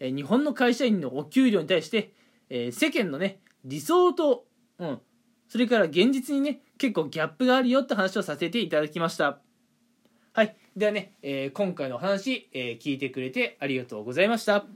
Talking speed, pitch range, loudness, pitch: 360 characters per minute, 150-245 Hz, -26 LUFS, 205 Hz